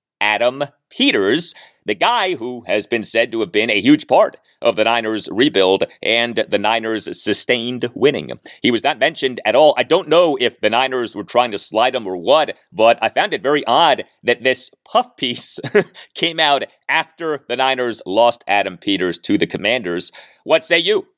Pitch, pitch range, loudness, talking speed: 120 Hz, 110-145 Hz, -17 LUFS, 185 wpm